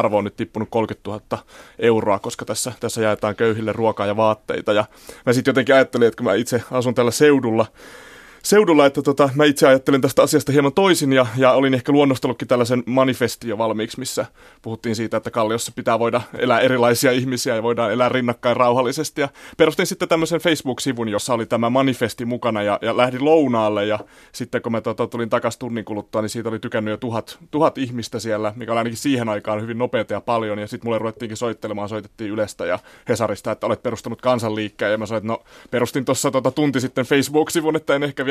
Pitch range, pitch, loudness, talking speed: 110-135 Hz, 120 Hz, -20 LUFS, 205 wpm